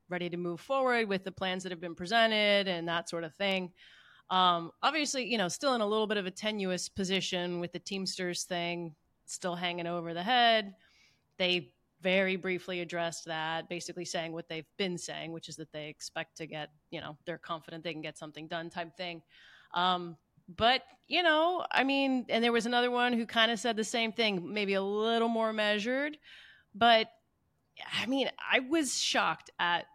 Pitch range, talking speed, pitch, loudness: 170-225 Hz, 195 wpm, 185 Hz, -31 LUFS